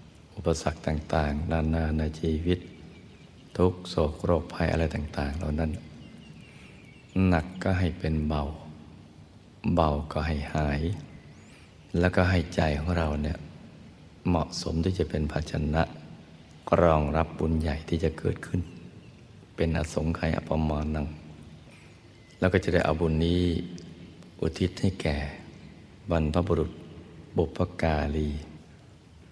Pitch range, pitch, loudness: 75-85 Hz, 80 Hz, -28 LUFS